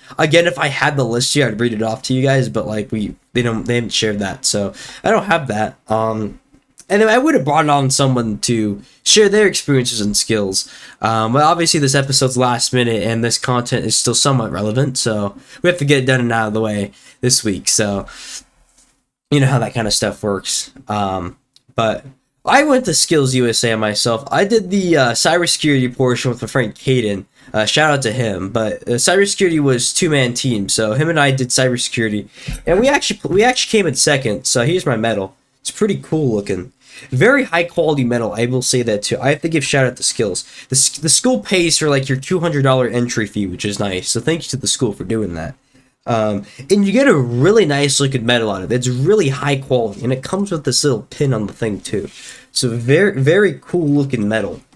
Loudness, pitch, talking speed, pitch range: -15 LUFS, 130 Hz, 225 wpm, 110-145 Hz